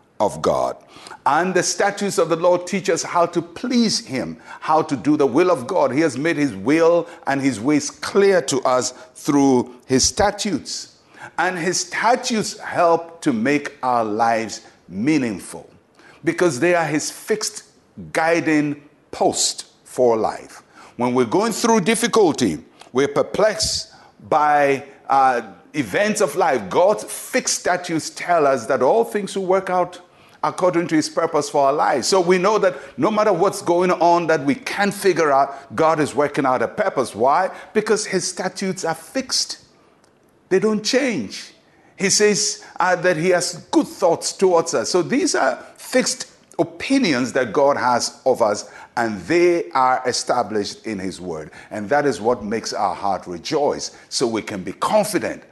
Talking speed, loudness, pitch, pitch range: 165 wpm, -19 LUFS, 170 Hz, 140-200 Hz